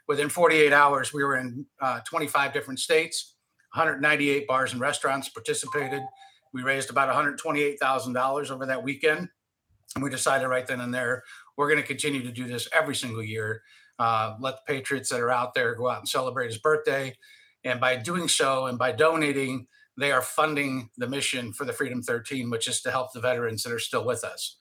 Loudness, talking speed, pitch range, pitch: -26 LUFS, 195 wpm, 125-150 Hz, 135 Hz